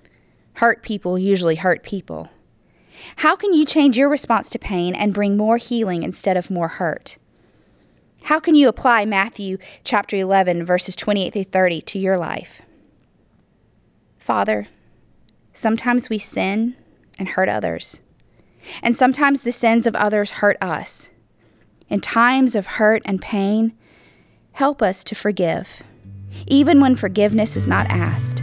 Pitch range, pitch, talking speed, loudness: 185-235 Hz, 205 Hz, 140 wpm, -18 LUFS